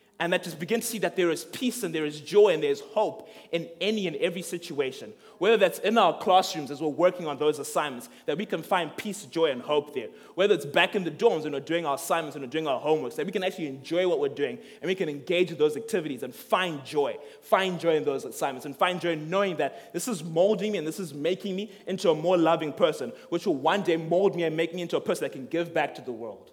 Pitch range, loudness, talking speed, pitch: 160-200 Hz, -27 LUFS, 275 wpm, 175 Hz